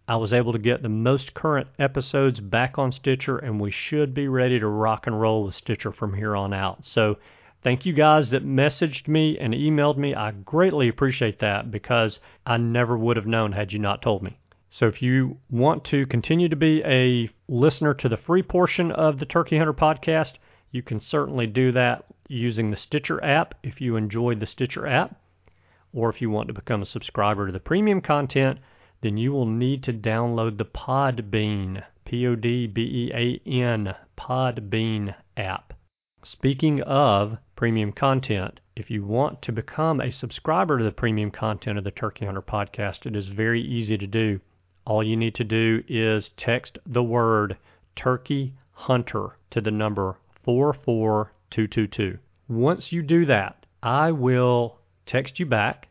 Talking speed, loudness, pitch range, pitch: 175 wpm, -24 LUFS, 105-135 Hz, 120 Hz